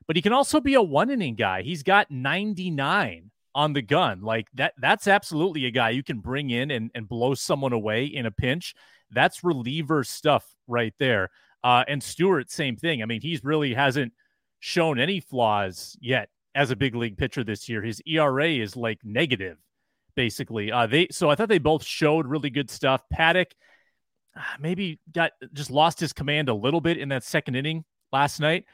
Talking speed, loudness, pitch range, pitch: 190 wpm, -24 LUFS, 120-165 Hz, 140 Hz